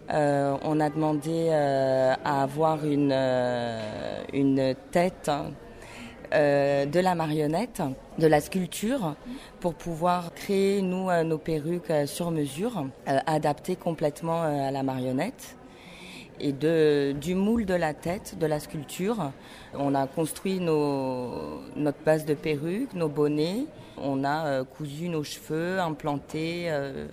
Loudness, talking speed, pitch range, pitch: -27 LUFS, 140 wpm, 140-175 Hz, 155 Hz